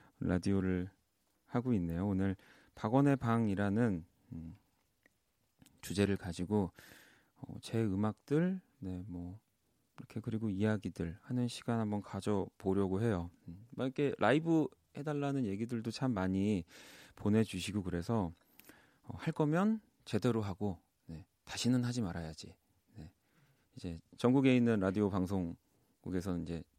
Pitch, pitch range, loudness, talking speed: 105 Hz, 90-120 Hz, -35 LUFS, 265 characters per minute